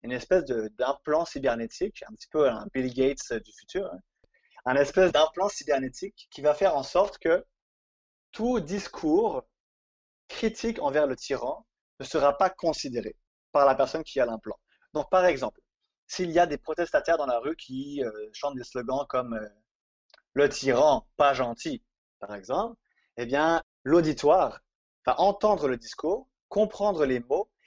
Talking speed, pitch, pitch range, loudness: 160 wpm, 155 Hz, 135-200 Hz, -27 LUFS